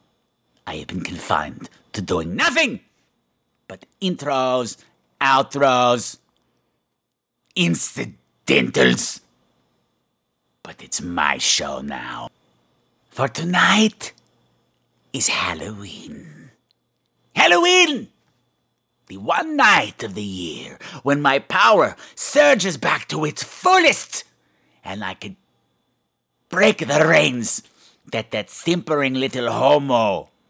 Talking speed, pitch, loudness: 90 wpm, 145 Hz, -18 LUFS